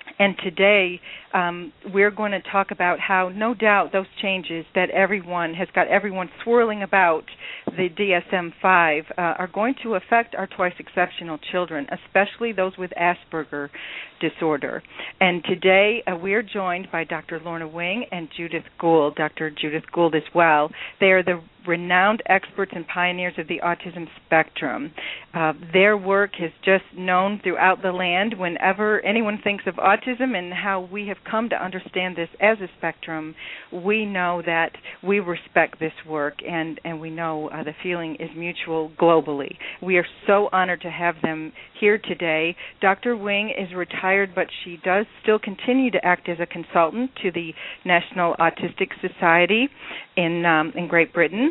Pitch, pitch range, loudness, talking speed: 180 Hz, 170-195 Hz, -22 LUFS, 165 wpm